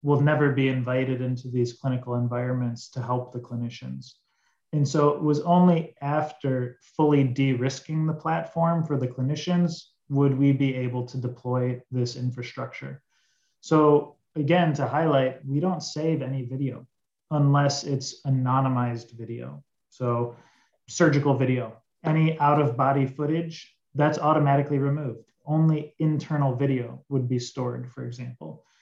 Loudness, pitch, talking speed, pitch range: -25 LUFS, 135 Hz, 135 wpm, 125-150 Hz